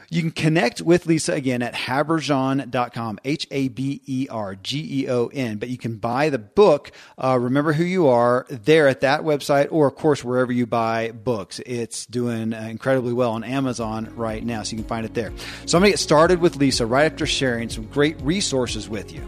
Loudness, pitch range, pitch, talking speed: -21 LUFS, 115-145 Hz, 130 Hz, 190 wpm